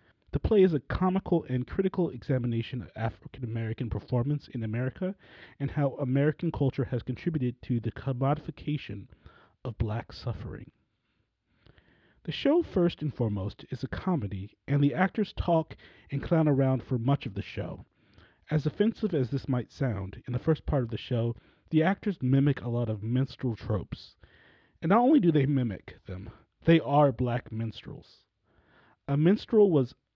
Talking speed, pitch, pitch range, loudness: 160 wpm, 130 Hz, 115-150 Hz, -29 LUFS